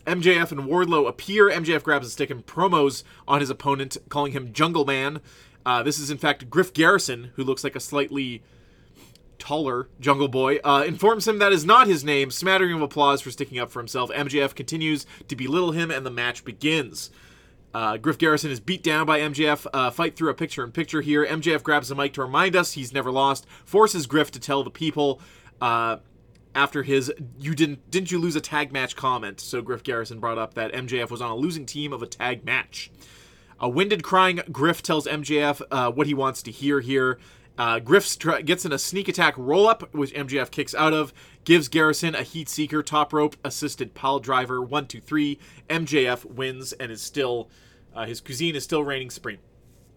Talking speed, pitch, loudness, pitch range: 205 wpm, 145 Hz, -23 LUFS, 130-155 Hz